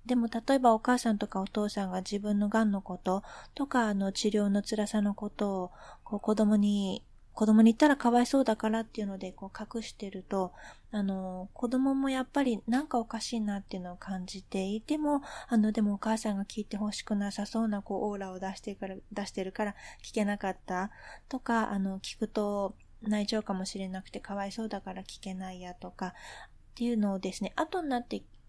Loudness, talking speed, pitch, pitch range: -31 LUFS, 385 characters per minute, 210 Hz, 195-225 Hz